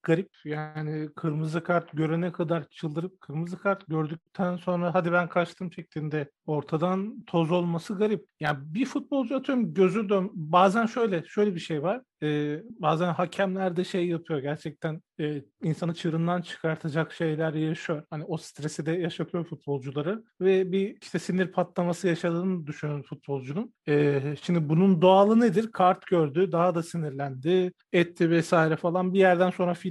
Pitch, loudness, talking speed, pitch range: 175 Hz, -27 LUFS, 150 wpm, 160-185 Hz